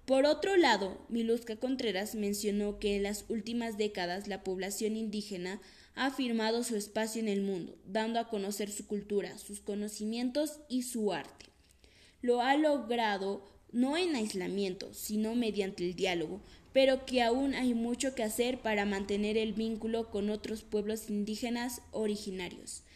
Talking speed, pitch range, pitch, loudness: 150 wpm, 200-240 Hz, 215 Hz, -34 LUFS